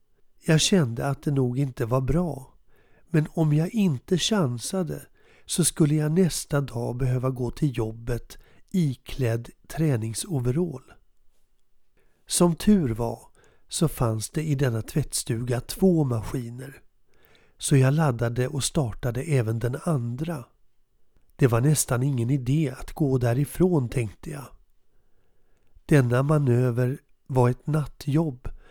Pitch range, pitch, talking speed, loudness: 120-155 Hz, 135 Hz, 120 wpm, -25 LUFS